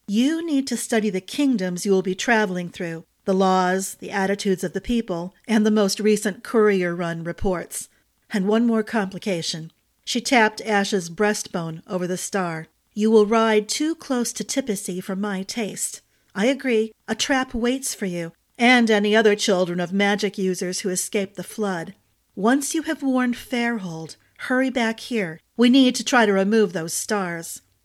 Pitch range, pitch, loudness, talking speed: 185-230 Hz, 210 Hz, -22 LUFS, 170 wpm